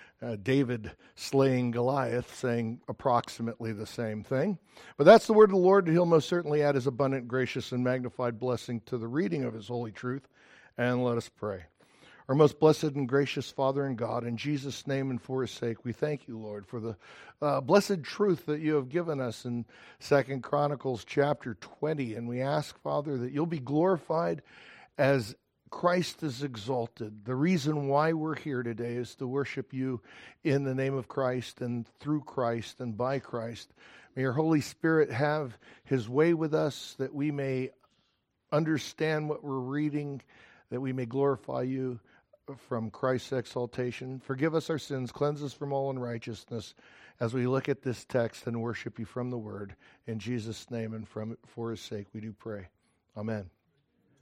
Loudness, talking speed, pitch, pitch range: -30 LUFS, 180 wpm, 130 Hz, 120-145 Hz